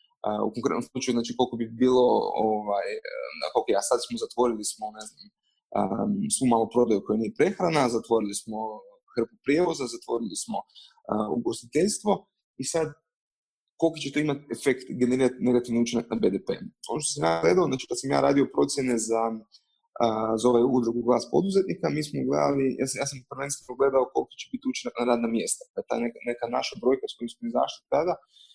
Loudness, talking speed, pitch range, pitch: -27 LUFS, 185 wpm, 115-195 Hz, 130 Hz